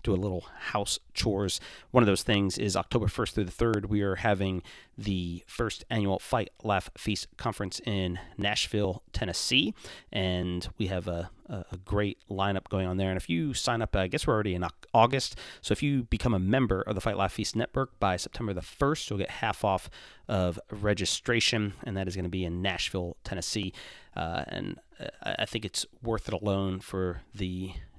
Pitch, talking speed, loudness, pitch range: 100 Hz, 195 wpm, -30 LUFS, 90-110 Hz